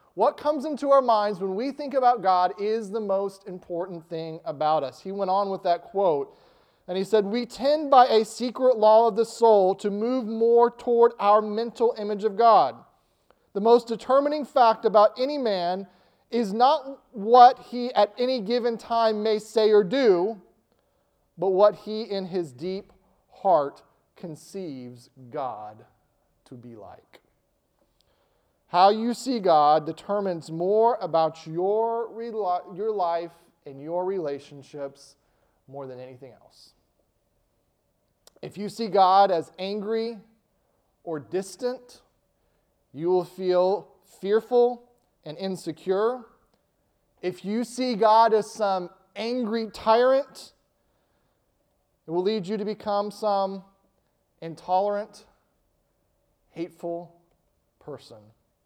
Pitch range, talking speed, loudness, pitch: 175-230 Hz, 130 wpm, -24 LUFS, 205 Hz